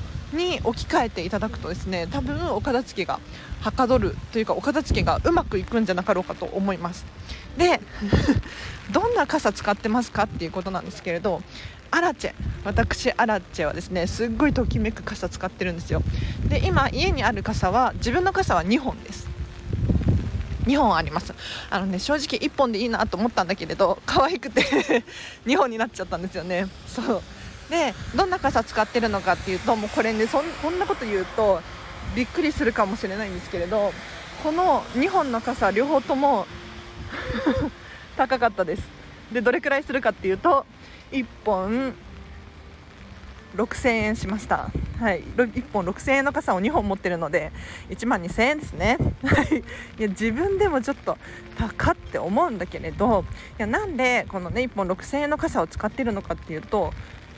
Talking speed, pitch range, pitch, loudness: 325 characters per minute, 185-270 Hz, 220 Hz, -24 LUFS